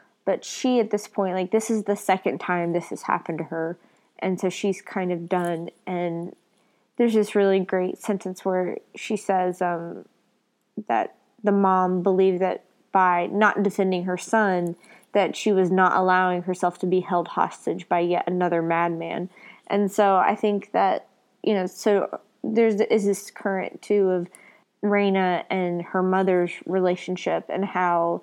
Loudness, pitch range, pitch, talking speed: -24 LUFS, 180-200 Hz, 185 Hz, 165 wpm